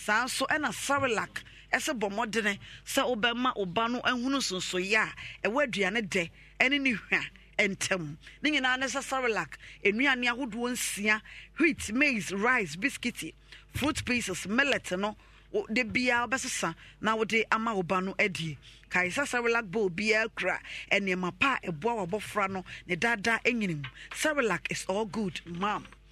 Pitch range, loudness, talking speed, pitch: 190-250 Hz, -29 LUFS, 150 wpm, 220 Hz